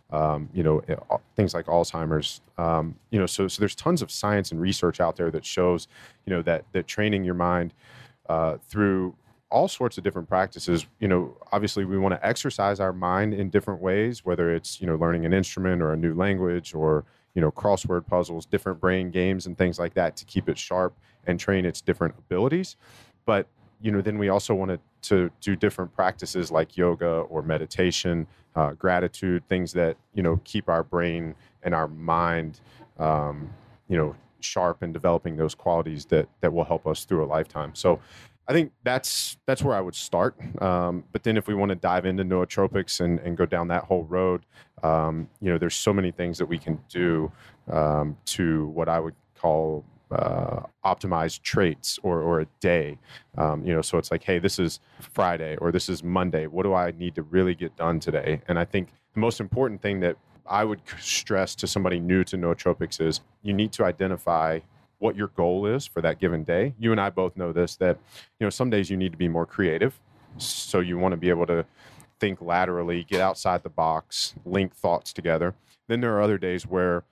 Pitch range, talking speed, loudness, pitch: 85-100 Hz, 205 wpm, -26 LUFS, 90 Hz